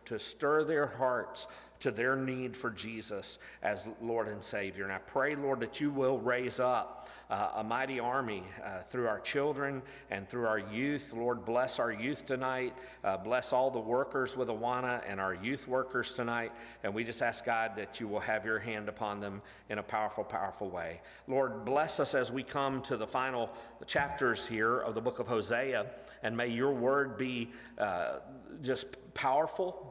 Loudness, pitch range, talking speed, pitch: -35 LUFS, 110-130 Hz, 185 wpm, 125 Hz